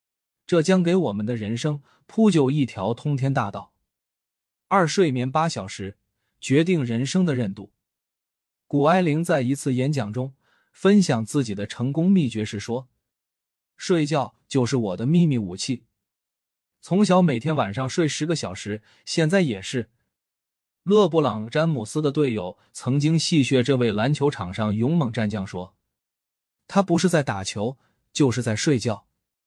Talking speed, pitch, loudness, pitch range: 220 characters per minute, 130 Hz, -23 LUFS, 105-155 Hz